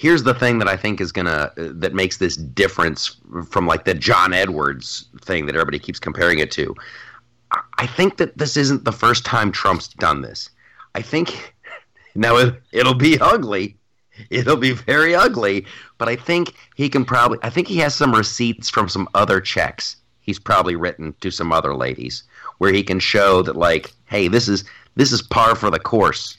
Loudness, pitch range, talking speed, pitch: -18 LUFS, 95-130 Hz, 200 wpm, 115 Hz